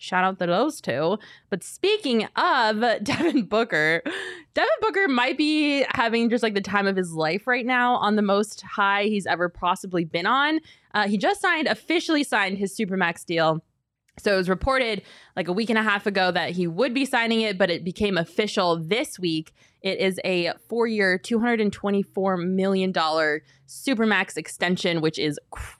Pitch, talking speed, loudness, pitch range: 200 Hz, 180 wpm, -23 LUFS, 180-235 Hz